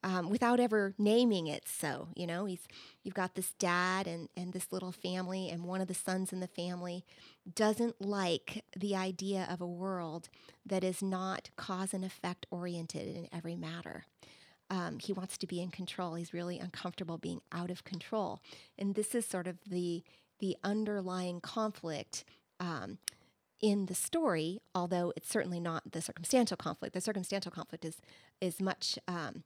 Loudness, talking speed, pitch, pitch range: -37 LUFS, 170 wpm, 185 Hz, 175-195 Hz